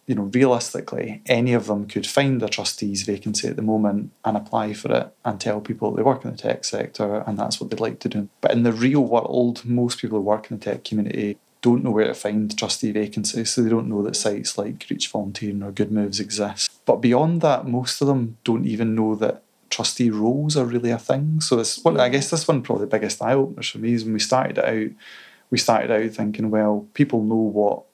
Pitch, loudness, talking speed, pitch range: 110 Hz, -22 LUFS, 240 wpm, 105-125 Hz